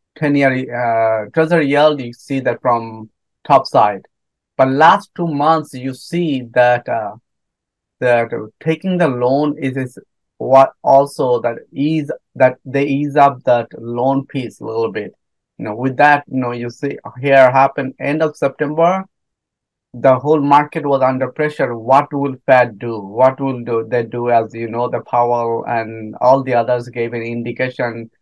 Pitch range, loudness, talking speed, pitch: 120-145 Hz, -16 LUFS, 165 wpm, 130 Hz